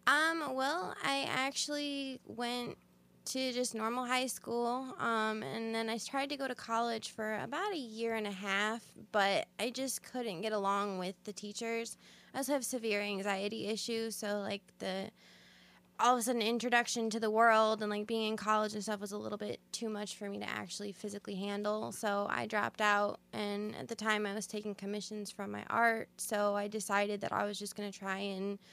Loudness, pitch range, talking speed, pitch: -36 LUFS, 205-235 Hz, 205 wpm, 215 Hz